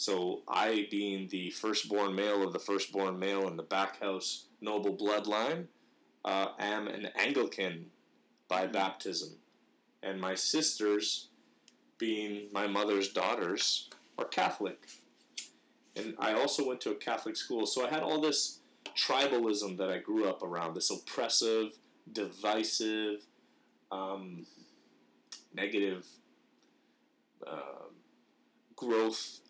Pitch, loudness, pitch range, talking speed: 105 Hz, -34 LUFS, 95-110 Hz, 115 wpm